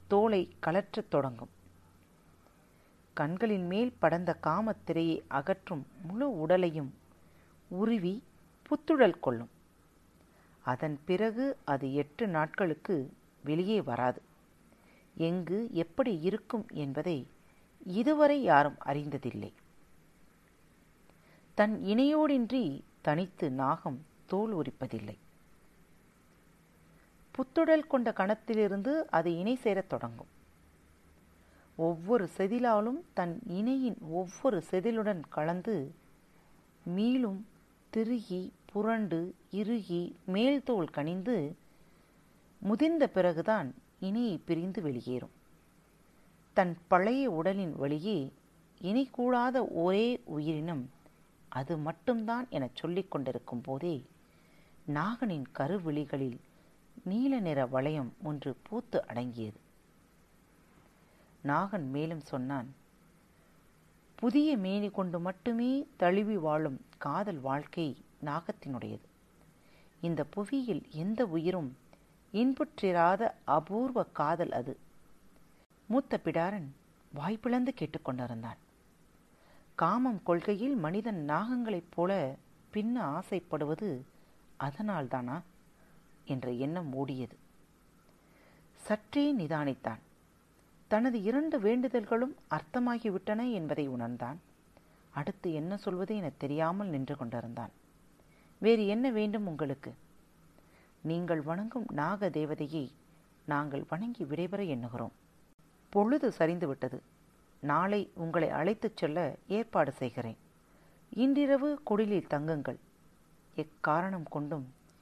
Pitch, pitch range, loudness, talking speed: 175 Hz, 145-220 Hz, -33 LUFS, 80 wpm